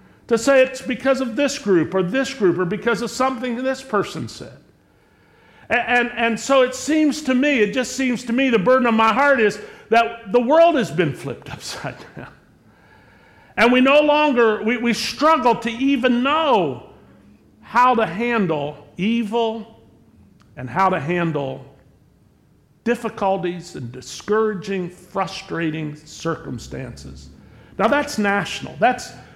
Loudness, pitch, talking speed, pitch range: -19 LUFS, 225 Hz, 145 wpm, 180-255 Hz